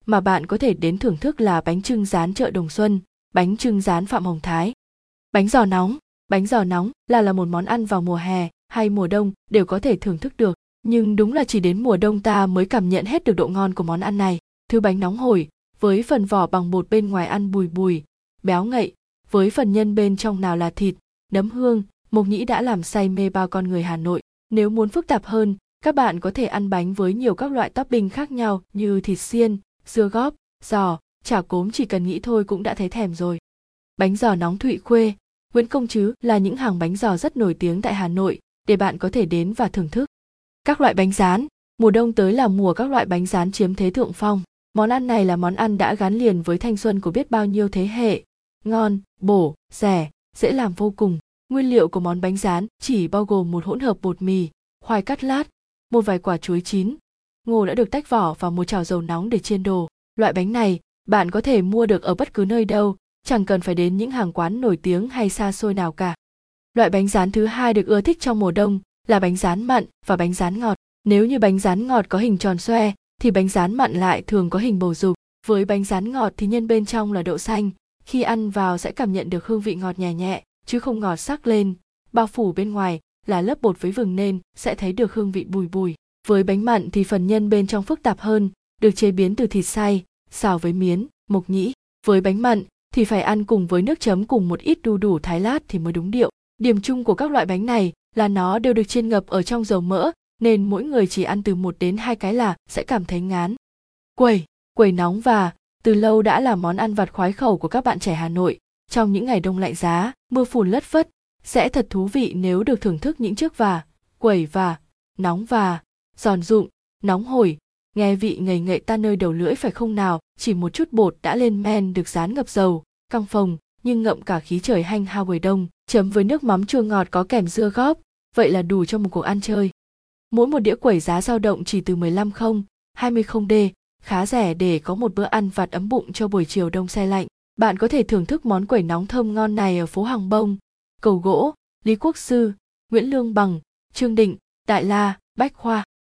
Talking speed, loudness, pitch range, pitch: 240 wpm, -21 LUFS, 185-225 Hz, 205 Hz